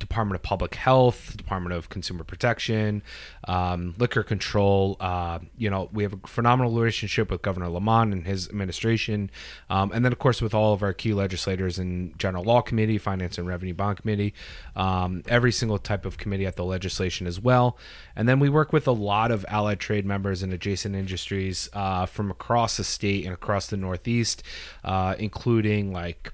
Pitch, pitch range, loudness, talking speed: 100 Hz, 95-110 Hz, -25 LUFS, 190 wpm